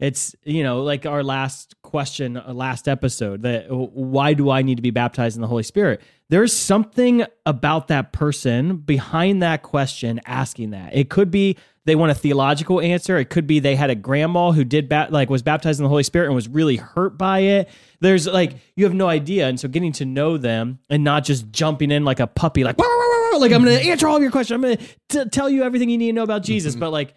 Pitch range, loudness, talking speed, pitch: 135-185 Hz, -19 LUFS, 245 wpm, 150 Hz